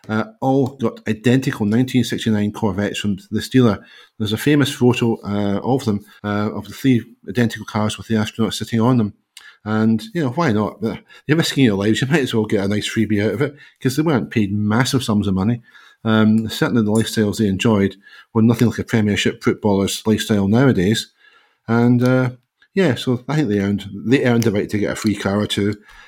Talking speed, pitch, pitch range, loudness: 205 wpm, 110 Hz, 105-125 Hz, -18 LUFS